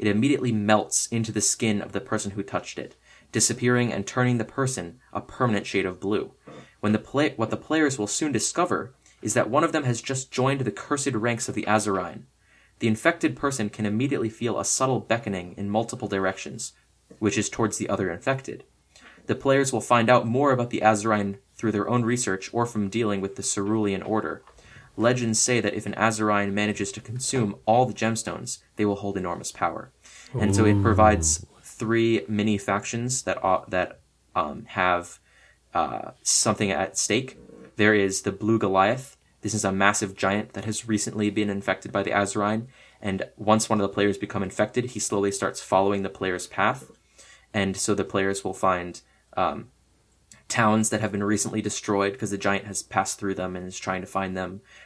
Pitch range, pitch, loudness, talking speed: 100-115 Hz, 105 Hz, -25 LUFS, 190 wpm